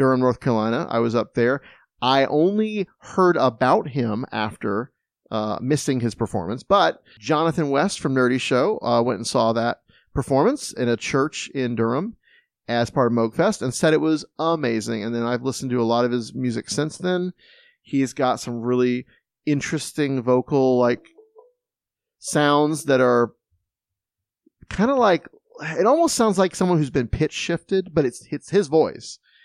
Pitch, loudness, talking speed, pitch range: 130 Hz, -22 LUFS, 165 wpm, 120-160 Hz